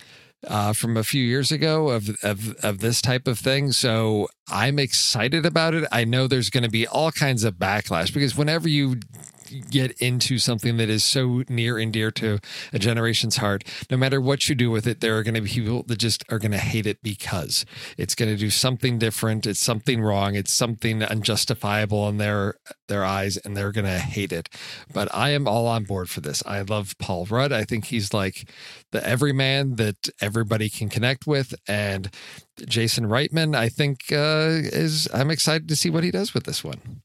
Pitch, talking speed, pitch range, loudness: 115 Hz, 205 wpm, 105-135 Hz, -23 LUFS